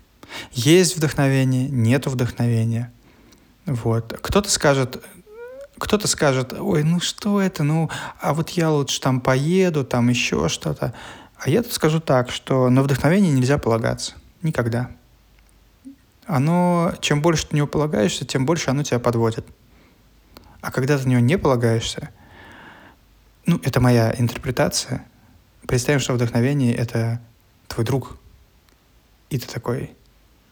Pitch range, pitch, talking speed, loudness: 120-155 Hz, 130 Hz, 130 wpm, -20 LUFS